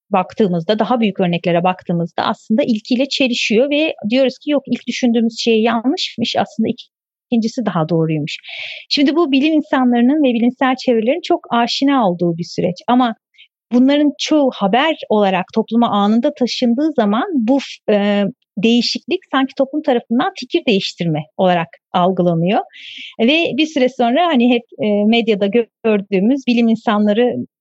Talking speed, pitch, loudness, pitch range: 130 wpm, 240 Hz, -16 LUFS, 210-270 Hz